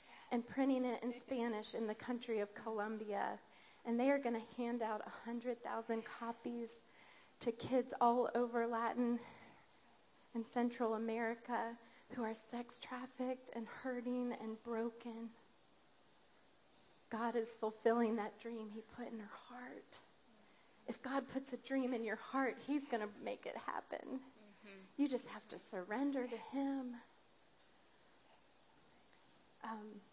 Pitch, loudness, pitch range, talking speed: 235 Hz, -42 LUFS, 225-250 Hz, 135 wpm